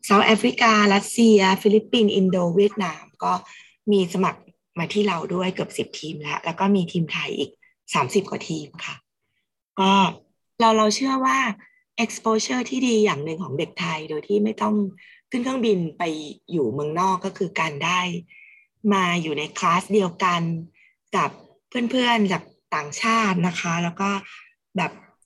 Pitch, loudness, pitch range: 195 Hz, -22 LUFS, 175-220 Hz